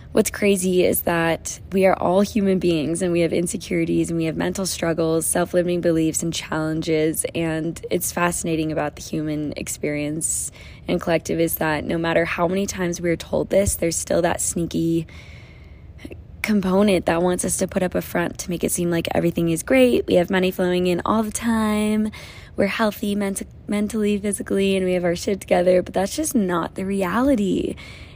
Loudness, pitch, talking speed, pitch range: -21 LUFS, 175 Hz, 185 wpm, 165-195 Hz